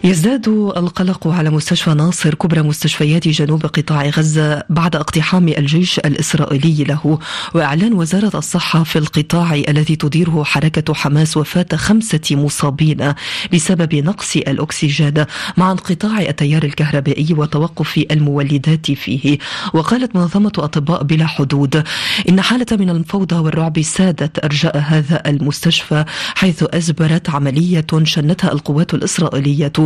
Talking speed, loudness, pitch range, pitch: 115 wpm, -14 LUFS, 150-175 Hz, 160 Hz